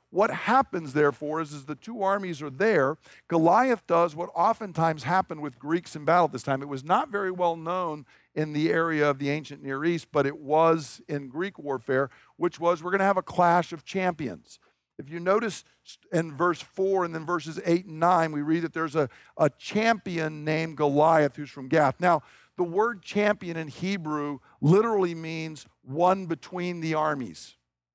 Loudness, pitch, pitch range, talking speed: -26 LUFS, 165 Hz, 150-180 Hz, 190 wpm